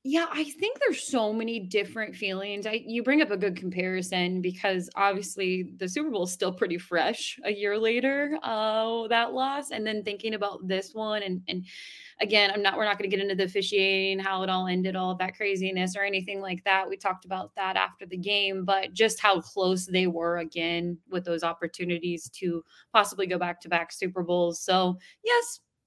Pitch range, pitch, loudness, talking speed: 180-215 Hz, 195 Hz, -28 LUFS, 200 wpm